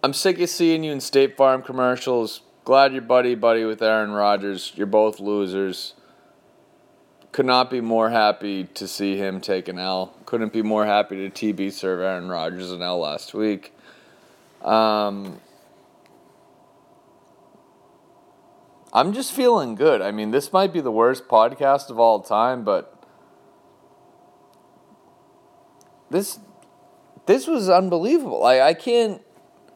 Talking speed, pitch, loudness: 135 wpm, 130 Hz, -21 LUFS